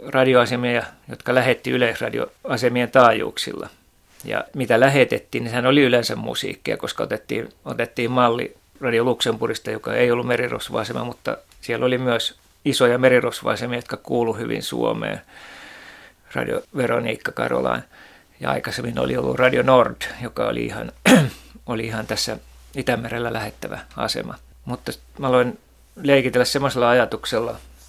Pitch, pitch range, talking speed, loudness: 120 Hz, 115-125 Hz, 125 wpm, -21 LUFS